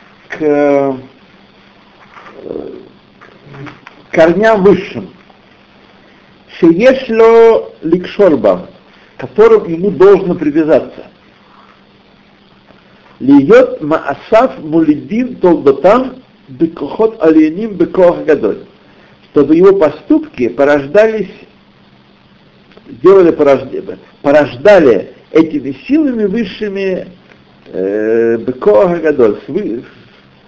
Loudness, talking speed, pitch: -10 LUFS, 55 wpm, 200 Hz